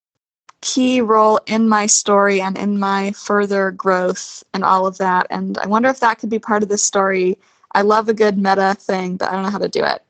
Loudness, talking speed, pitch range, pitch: -16 LUFS, 230 wpm, 190-215 Hz, 200 Hz